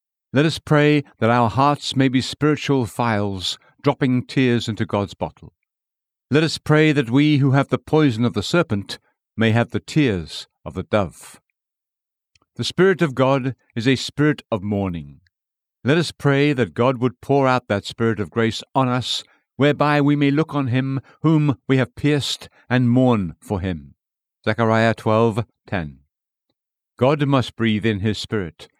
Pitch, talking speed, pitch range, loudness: 125 Hz, 165 wpm, 110-145 Hz, -20 LUFS